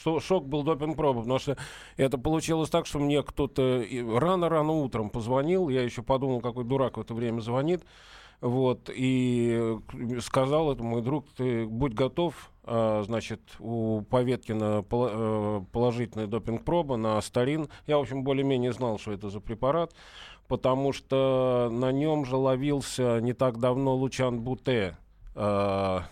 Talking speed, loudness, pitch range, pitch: 135 wpm, -28 LUFS, 115-140 Hz, 125 Hz